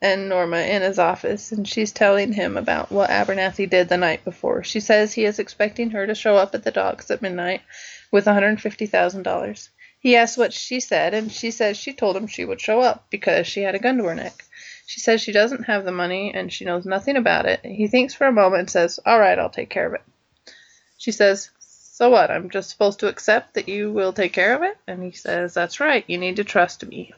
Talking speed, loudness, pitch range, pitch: 240 wpm, -20 LUFS, 190-230 Hz, 205 Hz